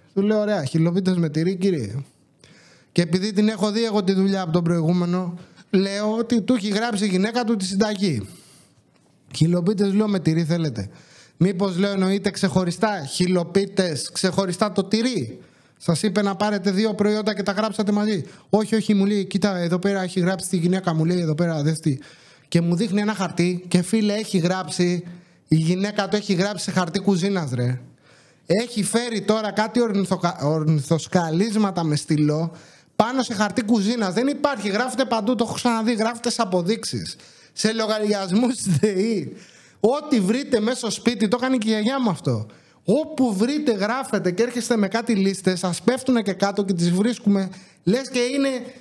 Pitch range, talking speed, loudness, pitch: 175-220 Hz, 170 wpm, -22 LUFS, 200 Hz